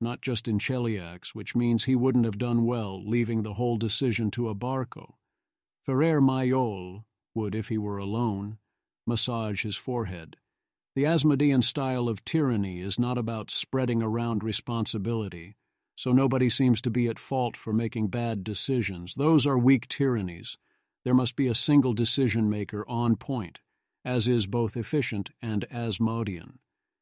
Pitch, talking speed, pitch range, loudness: 115 Hz, 150 wpm, 110-125 Hz, -27 LUFS